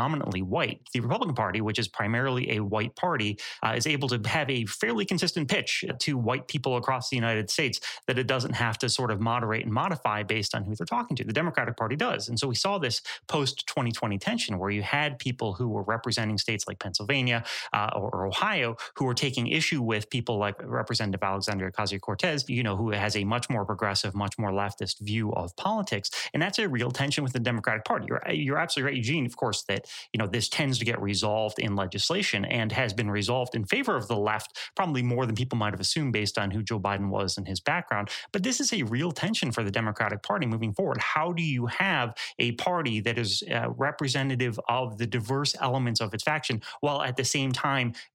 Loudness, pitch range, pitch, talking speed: -28 LUFS, 105-135 Hz, 120 Hz, 220 wpm